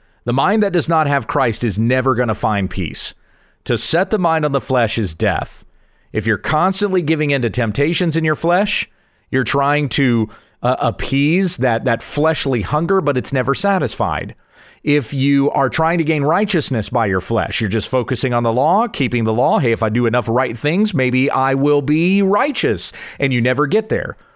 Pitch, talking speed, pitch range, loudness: 135 Hz, 200 wpm, 115-160 Hz, -17 LUFS